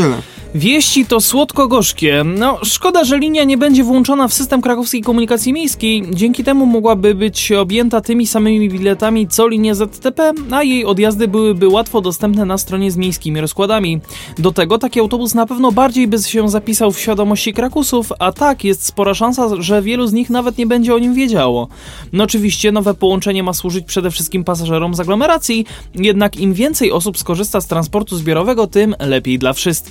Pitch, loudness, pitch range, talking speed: 215 Hz, -13 LUFS, 190-245 Hz, 180 wpm